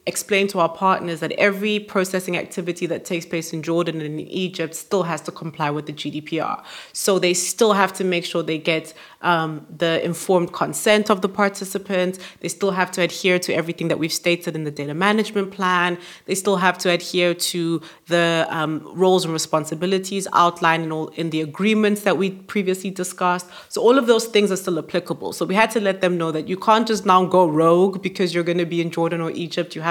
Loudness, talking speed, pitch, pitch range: -20 LUFS, 215 wpm, 175 Hz, 165-190 Hz